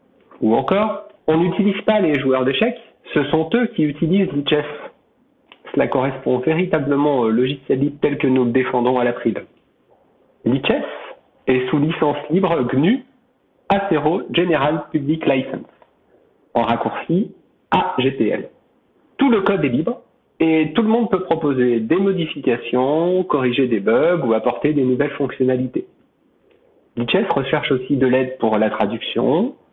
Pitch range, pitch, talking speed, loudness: 130-165 Hz, 145 Hz, 140 wpm, -19 LUFS